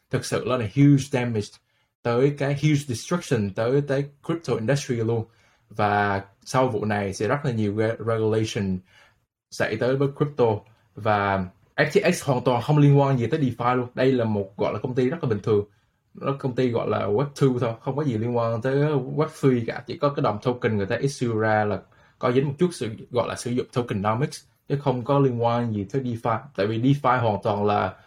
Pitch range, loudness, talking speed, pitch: 110-140 Hz, -24 LUFS, 210 wpm, 120 Hz